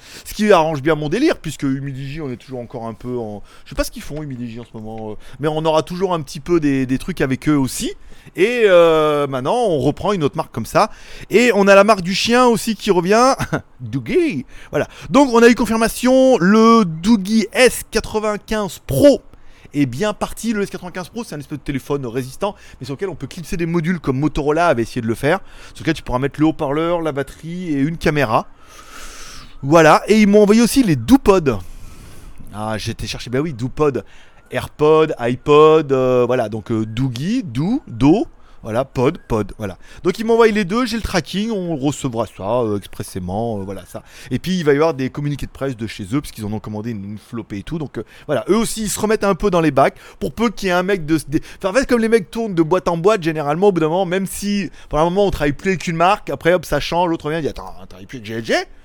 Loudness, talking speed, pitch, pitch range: -17 LUFS, 240 wpm, 160 Hz, 130-205 Hz